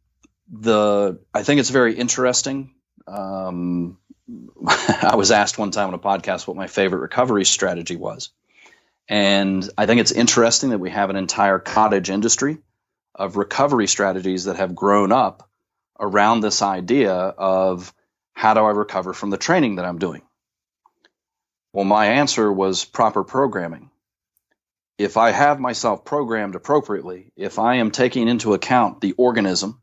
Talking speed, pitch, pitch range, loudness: 150 wpm, 105 Hz, 95-115 Hz, -19 LUFS